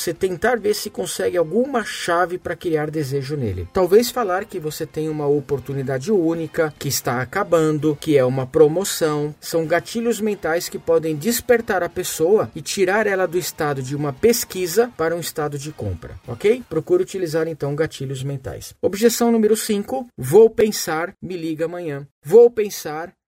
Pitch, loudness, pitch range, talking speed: 170 Hz, -20 LUFS, 150-210 Hz, 160 wpm